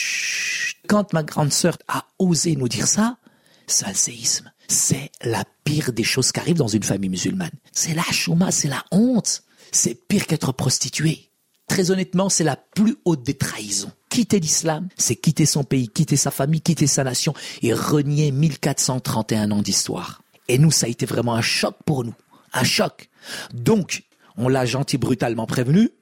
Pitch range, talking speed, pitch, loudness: 130-180 Hz, 175 wpm, 155 Hz, -20 LUFS